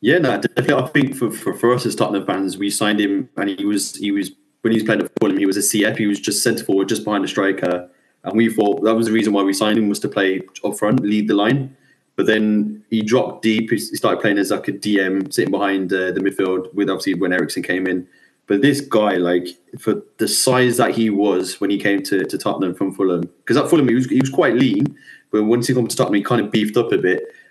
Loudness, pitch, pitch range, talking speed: -18 LUFS, 105 Hz, 100-120 Hz, 265 wpm